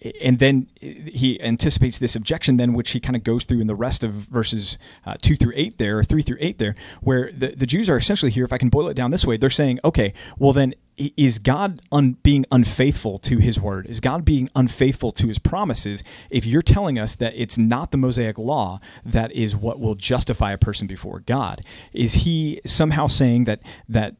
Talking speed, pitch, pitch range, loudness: 220 wpm, 125 Hz, 110-135 Hz, -20 LUFS